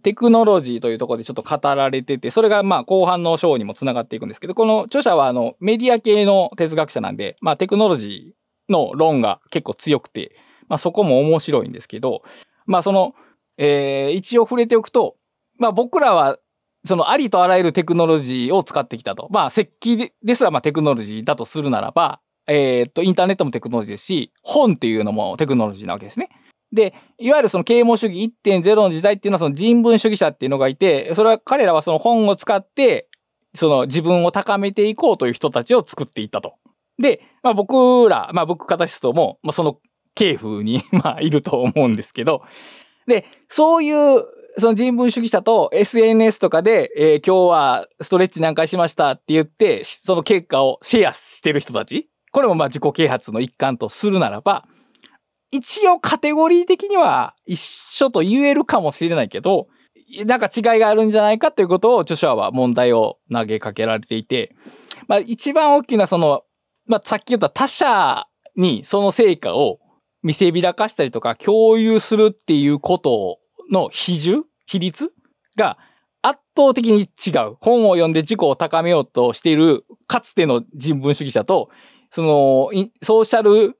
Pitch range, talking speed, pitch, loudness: 155-235 Hz, 375 characters per minute, 195 Hz, -17 LUFS